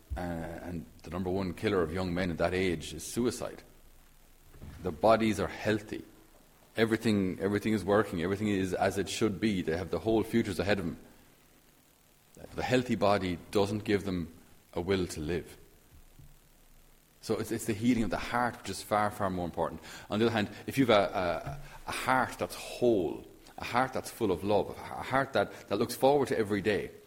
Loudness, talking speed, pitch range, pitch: -31 LUFS, 195 wpm, 85-110 Hz, 100 Hz